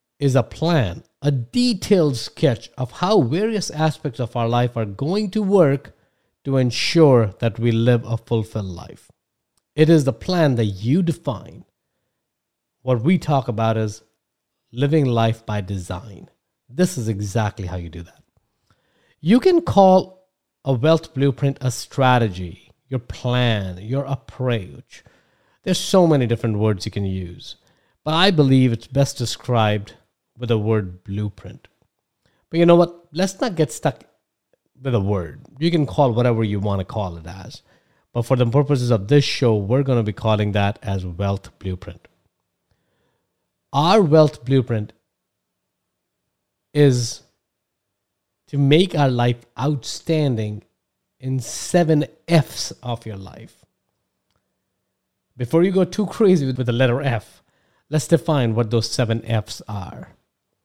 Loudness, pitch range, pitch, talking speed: -20 LUFS, 110-150 Hz, 125 Hz, 145 wpm